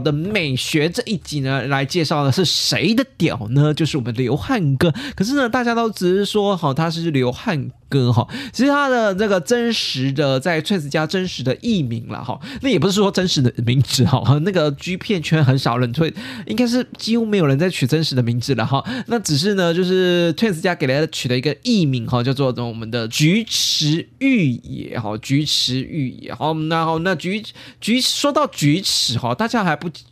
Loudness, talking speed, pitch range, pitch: -18 LUFS, 305 characters per minute, 135-205 Hz, 160 Hz